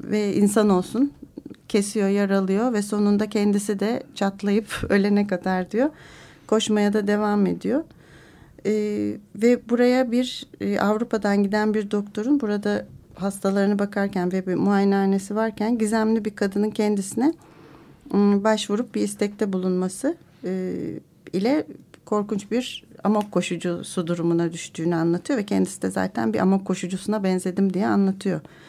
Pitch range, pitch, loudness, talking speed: 185-215 Hz, 205 Hz, -23 LUFS, 125 wpm